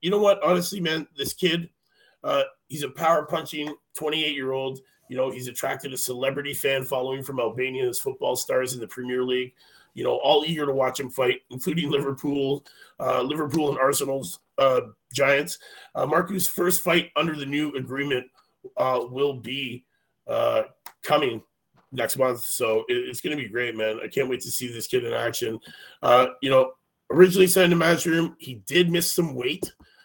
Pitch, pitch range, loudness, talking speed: 140 Hz, 130-170 Hz, -24 LUFS, 180 wpm